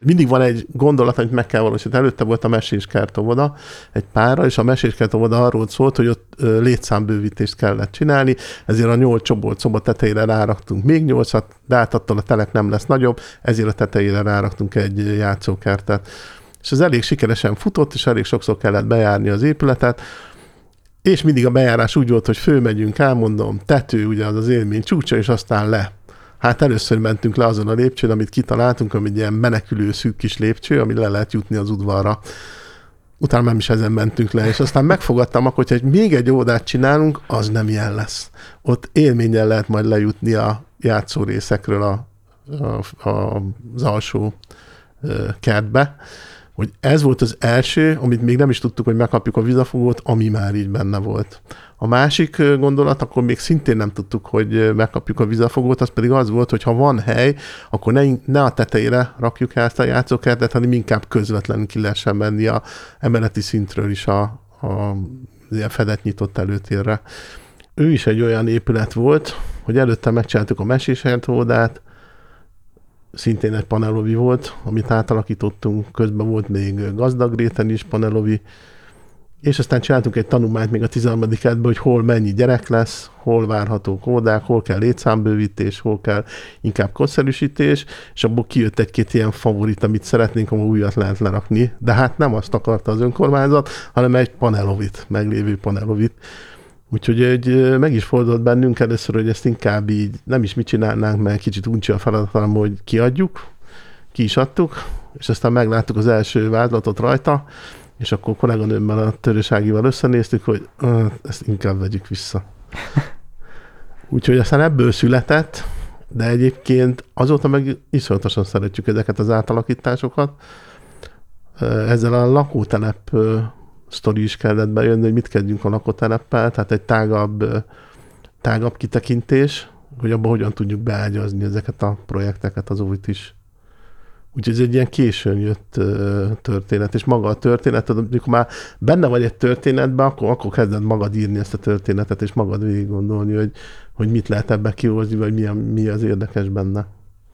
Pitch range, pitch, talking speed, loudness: 105-125 Hz, 115 Hz, 160 wpm, -17 LUFS